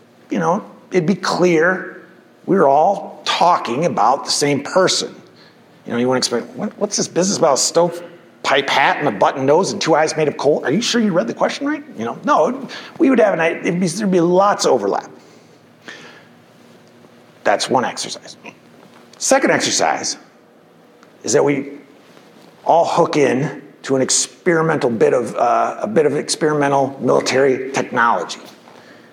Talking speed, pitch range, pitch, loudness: 165 wpm, 145-200 Hz, 170 Hz, -17 LUFS